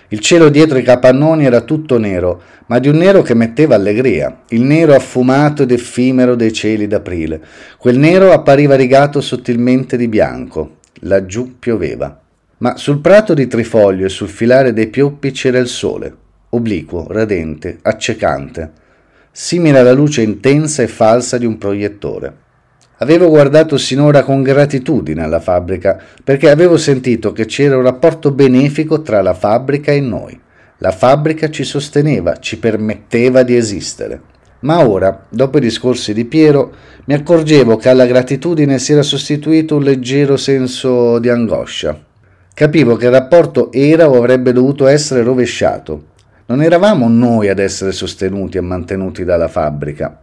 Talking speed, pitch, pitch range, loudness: 150 wpm, 125 Hz, 110-145 Hz, -11 LUFS